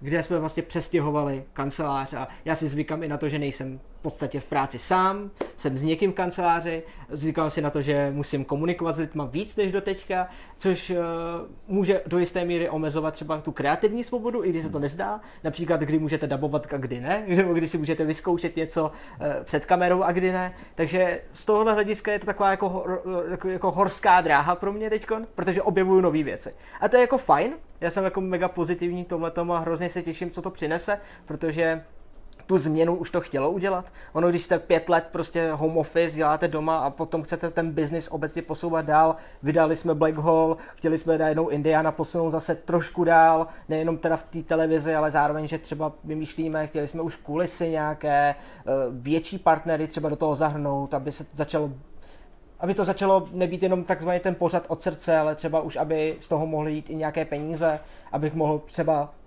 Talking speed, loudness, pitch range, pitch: 195 wpm, -25 LUFS, 155-180 Hz, 165 Hz